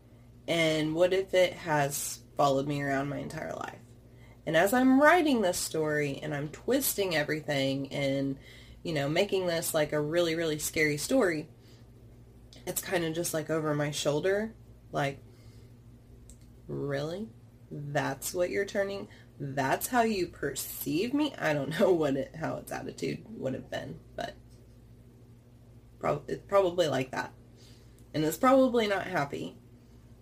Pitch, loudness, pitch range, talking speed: 145 Hz, -30 LUFS, 120-170 Hz, 145 wpm